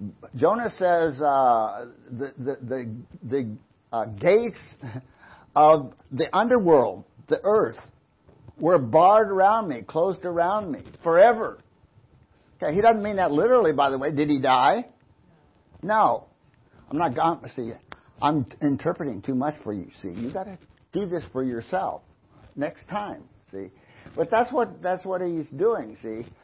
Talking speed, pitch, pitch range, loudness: 145 wpm, 150 Hz, 125-185 Hz, -23 LUFS